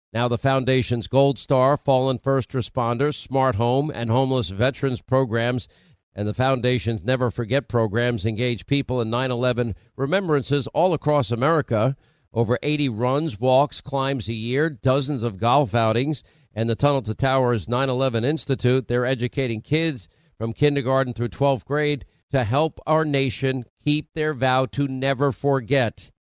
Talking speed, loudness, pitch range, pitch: 150 wpm, -22 LUFS, 120-140 Hz, 130 Hz